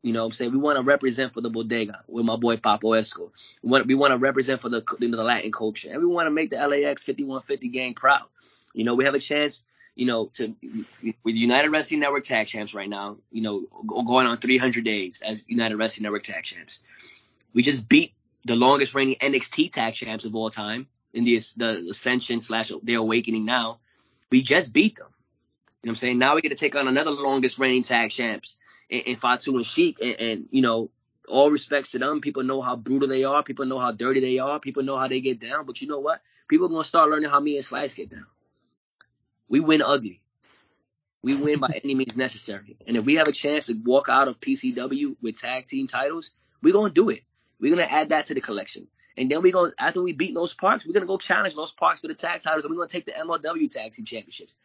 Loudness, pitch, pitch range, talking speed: -23 LUFS, 130 Hz, 115-145 Hz, 245 wpm